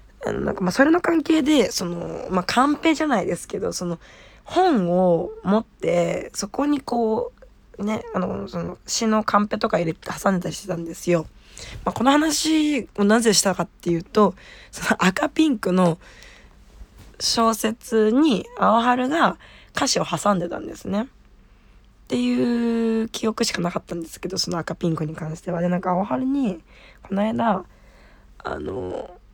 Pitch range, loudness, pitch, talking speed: 175-235 Hz, -22 LUFS, 205 Hz, 290 characters per minute